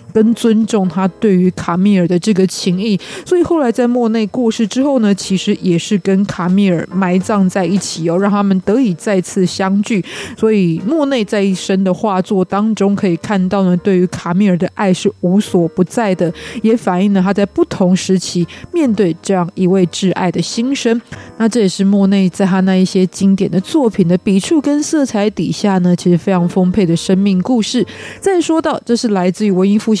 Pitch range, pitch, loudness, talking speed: 185-220 Hz, 195 Hz, -14 LUFS, 295 characters per minute